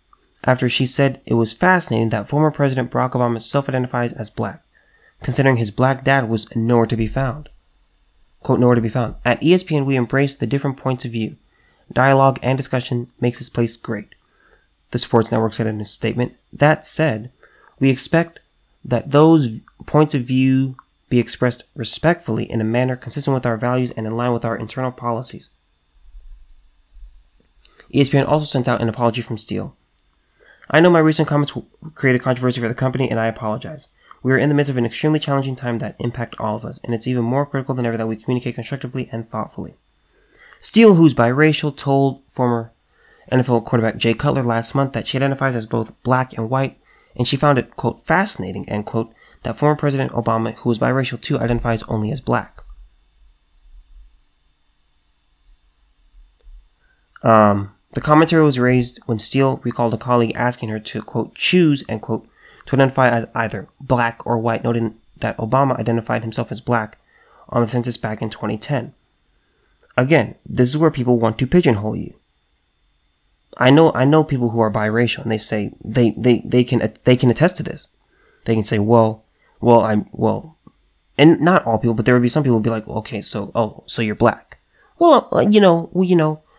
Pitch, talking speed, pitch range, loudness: 120 Hz, 185 wpm, 110-135 Hz, -18 LUFS